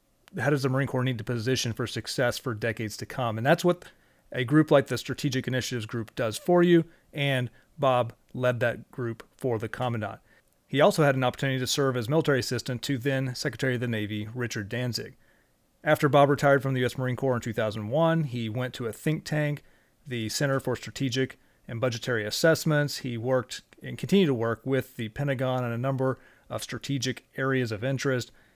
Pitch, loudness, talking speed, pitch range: 130 Hz, -27 LUFS, 195 wpm, 120-140 Hz